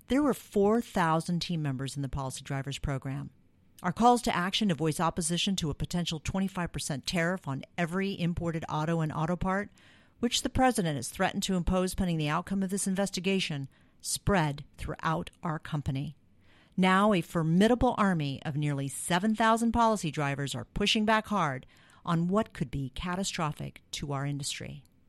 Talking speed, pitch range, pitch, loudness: 160 wpm, 140-195 Hz, 170 Hz, -30 LUFS